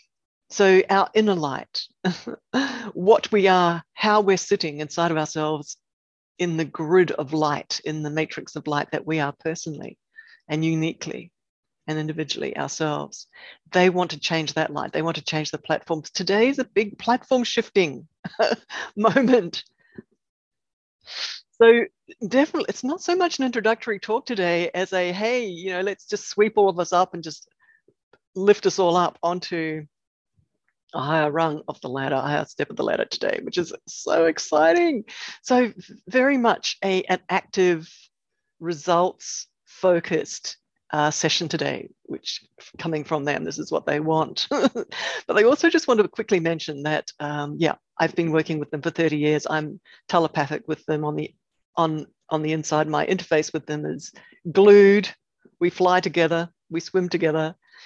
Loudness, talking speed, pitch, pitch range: -22 LUFS, 165 wpm, 170 Hz, 155-205 Hz